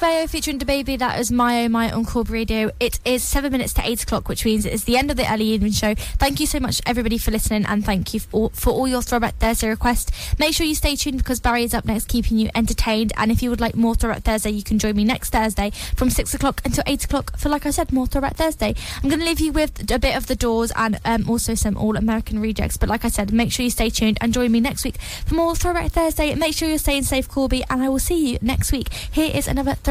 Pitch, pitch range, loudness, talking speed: 240 Hz, 225-280 Hz, -21 LUFS, 275 wpm